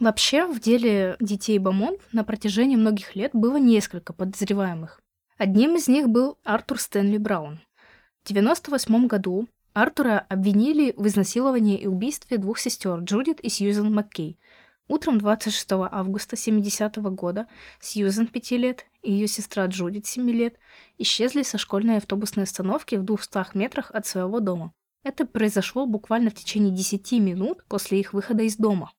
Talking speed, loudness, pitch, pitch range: 145 wpm, -24 LUFS, 215 Hz, 200-235 Hz